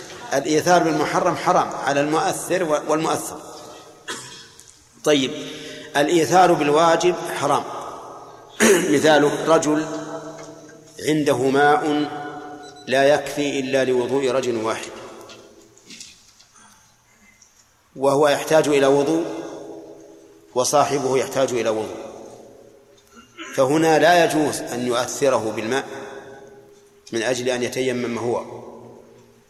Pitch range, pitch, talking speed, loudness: 135-160 Hz, 145 Hz, 80 wpm, -19 LUFS